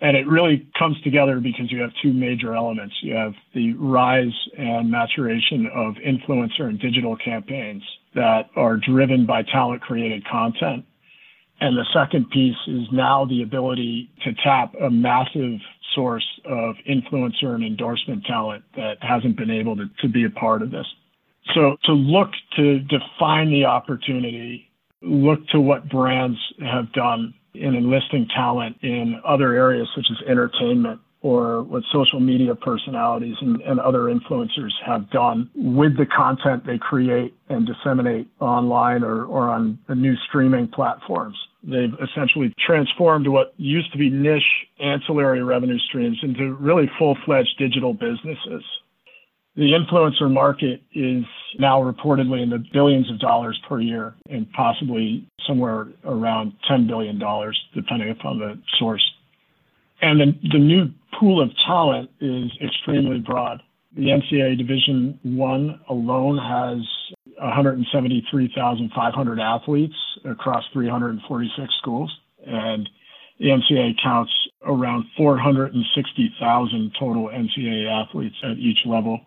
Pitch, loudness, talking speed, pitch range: 130 Hz, -20 LUFS, 135 wpm, 120-145 Hz